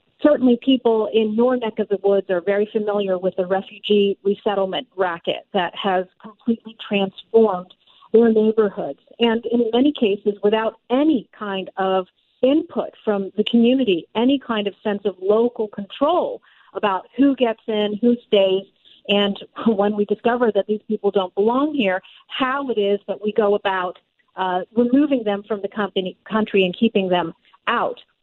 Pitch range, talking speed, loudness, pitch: 195-230 Hz, 160 wpm, -20 LUFS, 210 Hz